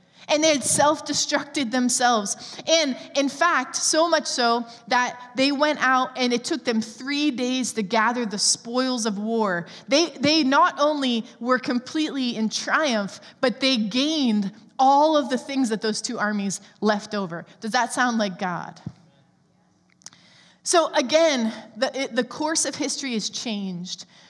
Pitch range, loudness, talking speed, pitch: 220-290 Hz, -22 LUFS, 155 wpm, 250 Hz